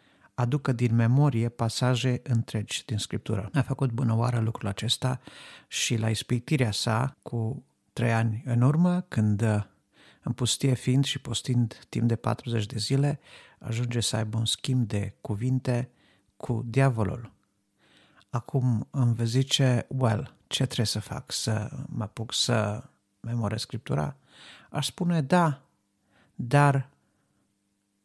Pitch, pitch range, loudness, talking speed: 120 Hz, 110-130 Hz, -27 LUFS, 130 wpm